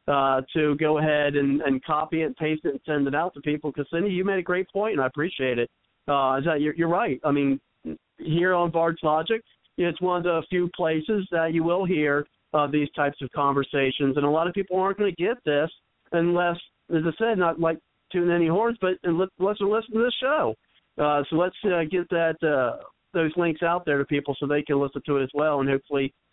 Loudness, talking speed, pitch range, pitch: -25 LUFS, 235 wpm, 145-175 Hz, 160 Hz